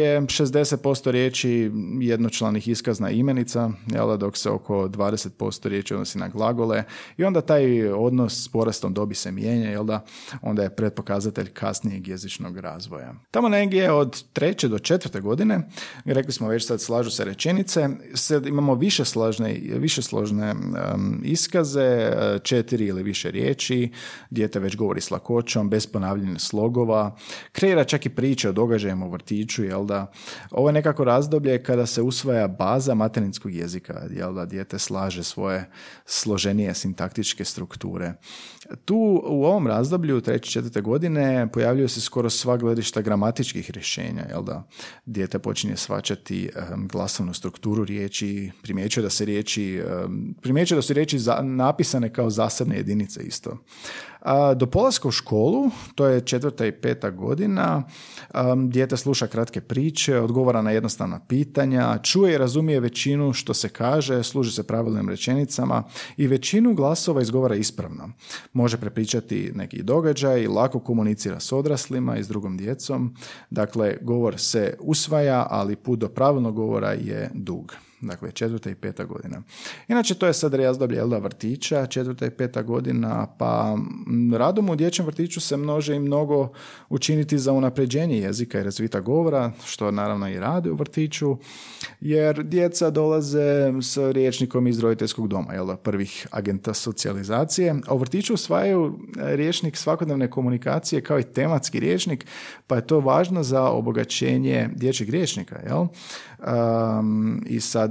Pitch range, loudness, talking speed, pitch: 110-145 Hz, -23 LUFS, 140 wpm, 125 Hz